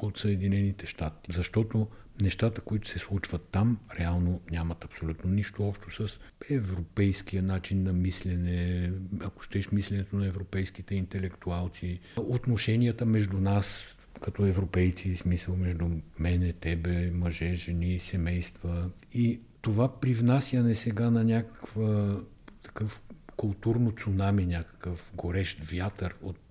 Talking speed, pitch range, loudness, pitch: 110 wpm, 90-105 Hz, -31 LUFS, 95 Hz